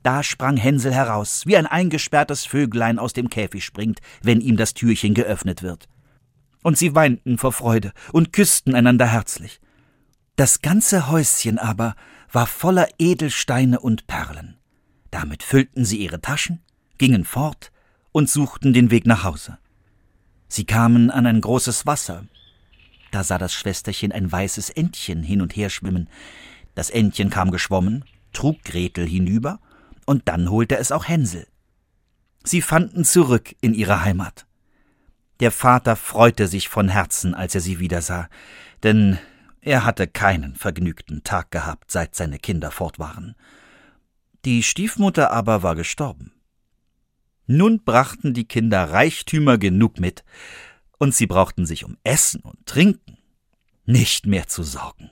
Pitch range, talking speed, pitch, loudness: 95-135 Hz, 145 wpm, 115 Hz, -19 LUFS